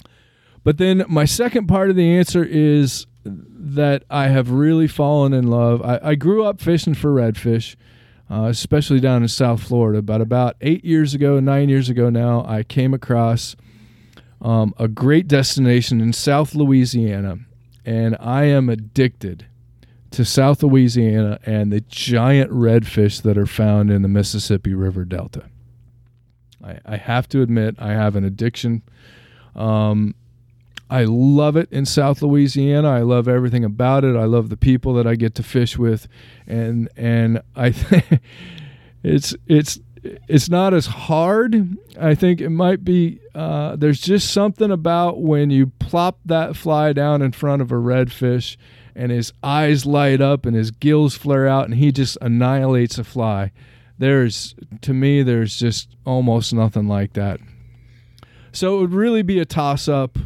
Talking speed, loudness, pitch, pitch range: 160 wpm, -17 LUFS, 125 Hz, 115-145 Hz